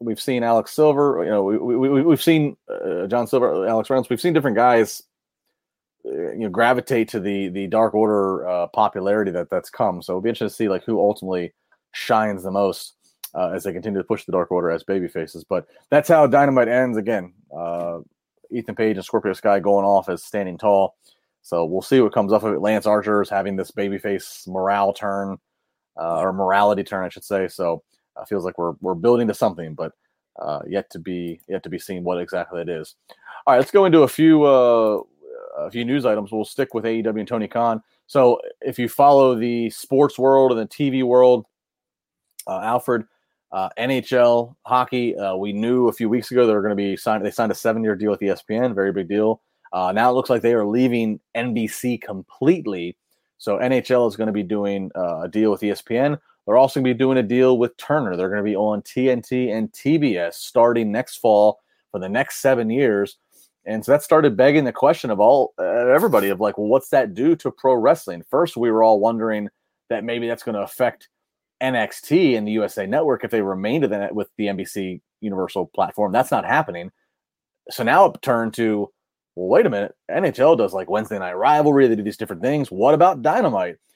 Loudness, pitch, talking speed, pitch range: -20 LUFS, 110 Hz, 210 wpm, 100-125 Hz